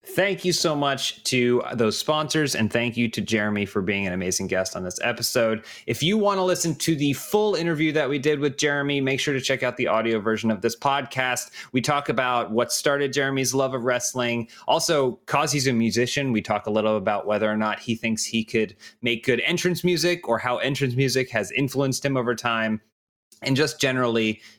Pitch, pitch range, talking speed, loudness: 125 Hz, 115-145 Hz, 210 wpm, -23 LUFS